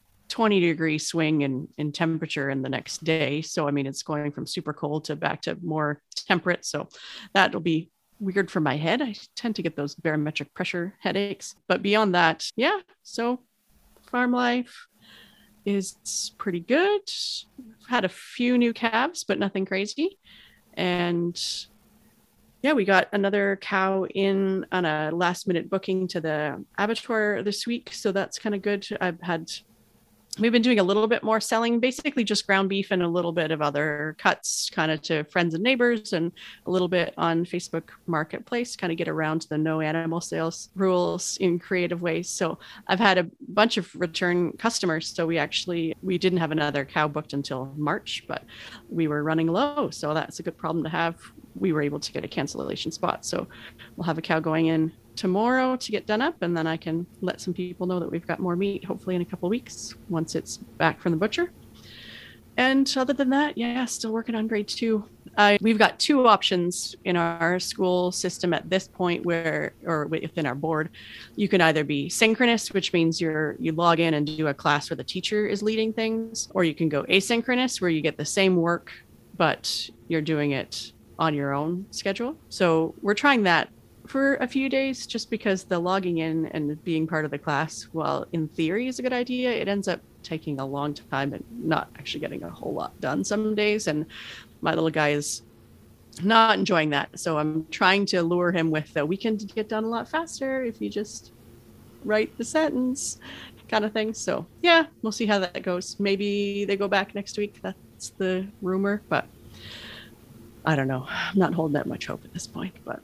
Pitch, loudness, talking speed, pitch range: 180 Hz, -25 LUFS, 195 wpm, 160-215 Hz